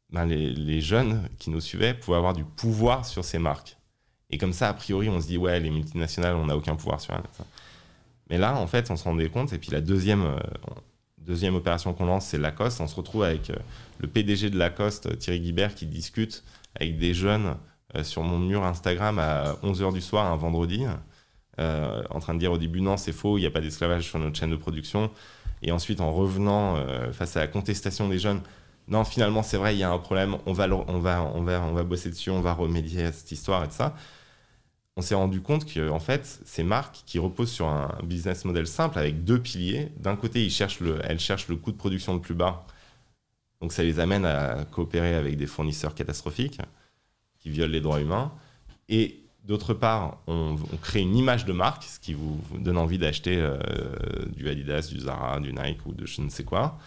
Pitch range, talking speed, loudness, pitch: 80-100 Hz, 225 wpm, -28 LUFS, 90 Hz